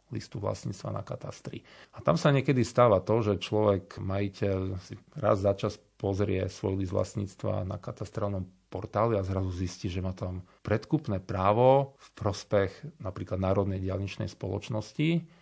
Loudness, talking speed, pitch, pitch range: -30 LUFS, 150 wpm, 100 Hz, 95-110 Hz